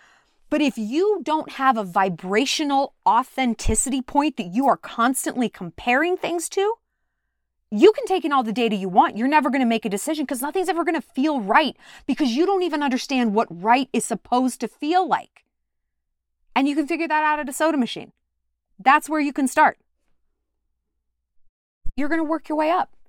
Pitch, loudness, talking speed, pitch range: 275 Hz, -21 LUFS, 190 wpm, 230-315 Hz